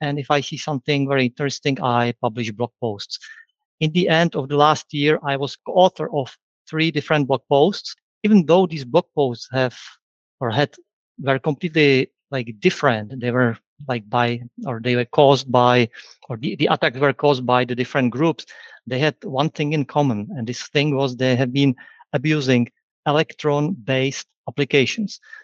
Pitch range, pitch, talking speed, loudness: 125-155 Hz, 140 Hz, 170 wpm, -20 LUFS